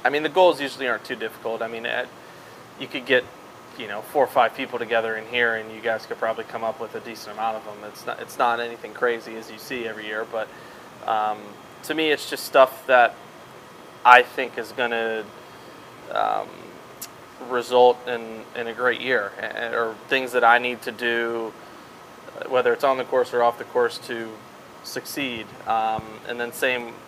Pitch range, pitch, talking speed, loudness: 110-125 Hz, 115 Hz, 195 wpm, -23 LUFS